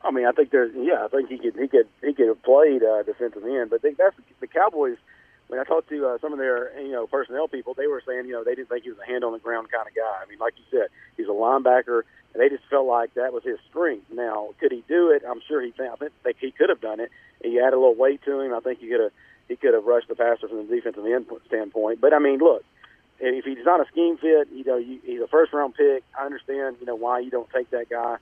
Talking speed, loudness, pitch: 285 wpm, -23 LUFS, 140 Hz